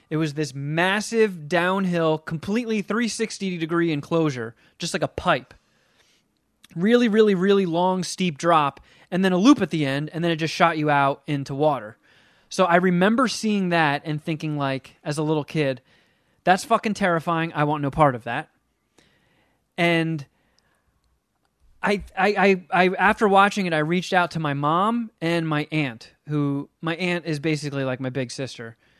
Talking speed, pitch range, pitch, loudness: 170 wpm, 150-190 Hz, 165 Hz, -22 LUFS